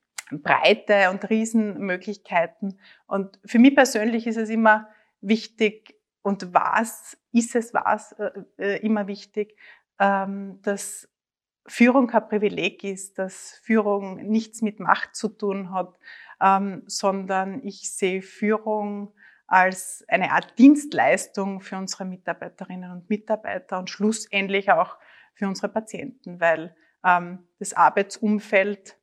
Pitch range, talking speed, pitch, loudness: 195-220 Hz, 120 wpm, 205 Hz, -23 LUFS